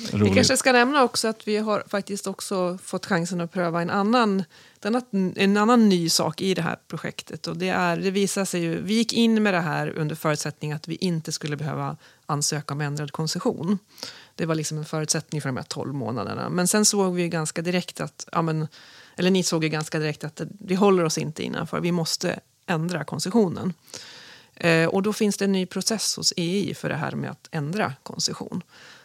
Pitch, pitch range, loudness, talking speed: 175 Hz, 160-200 Hz, -24 LUFS, 200 wpm